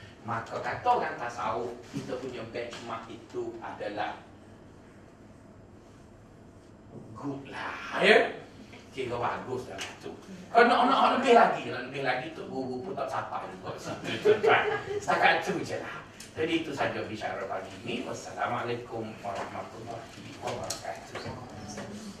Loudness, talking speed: -29 LUFS, 120 wpm